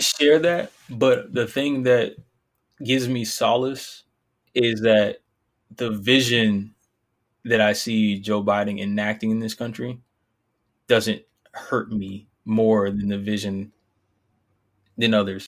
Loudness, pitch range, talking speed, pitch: -22 LUFS, 105-120 Hz, 120 wpm, 110 Hz